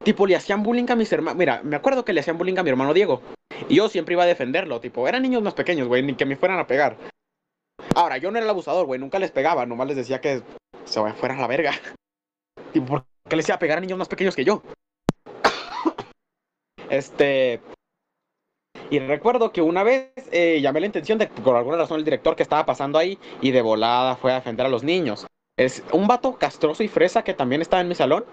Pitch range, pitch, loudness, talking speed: 140-215 Hz, 175 Hz, -22 LUFS, 230 wpm